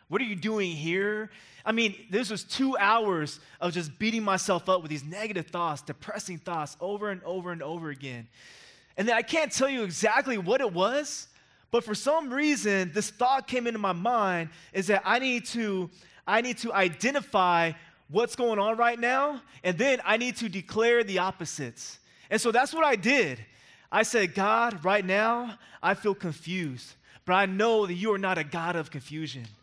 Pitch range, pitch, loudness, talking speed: 175-230 Hz, 200 Hz, -27 LUFS, 190 wpm